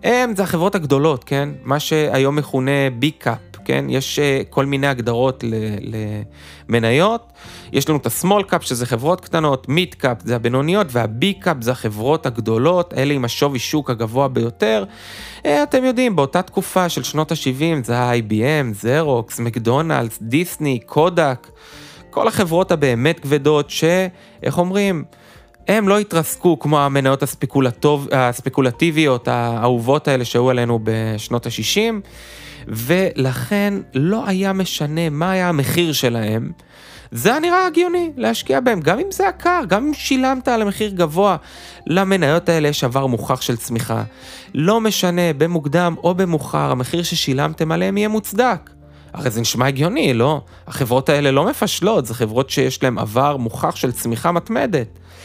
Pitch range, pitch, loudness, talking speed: 125-175 Hz, 145 Hz, -18 LUFS, 135 wpm